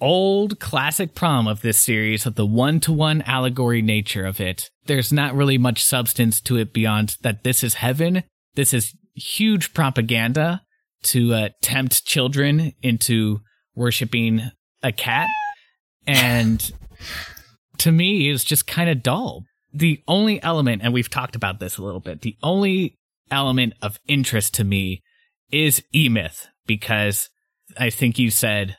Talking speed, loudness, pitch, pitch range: 150 wpm, -20 LUFS, 125 Hz, 110-155 Hz